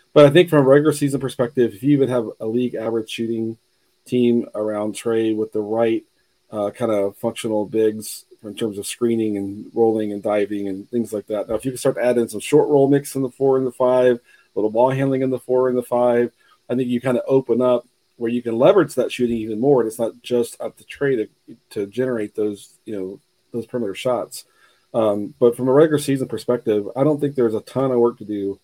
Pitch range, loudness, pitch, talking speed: 110-130 Hz, -20 LUFS, 120 Hz, 240 wpm